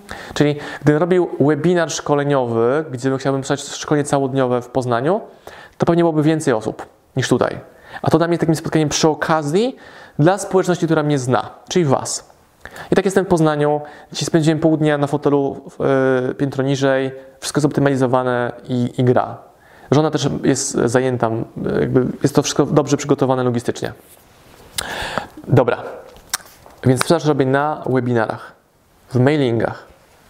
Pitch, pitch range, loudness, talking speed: 145 Hz, 130-155 Hz, -18 LUFS, 145 wpm